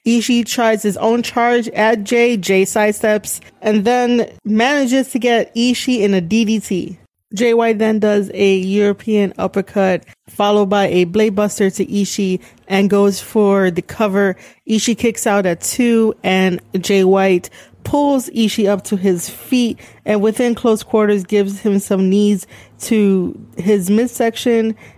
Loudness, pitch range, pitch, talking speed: -15 LUFS, 195-230 Hz, 210 Hz, 145 wpm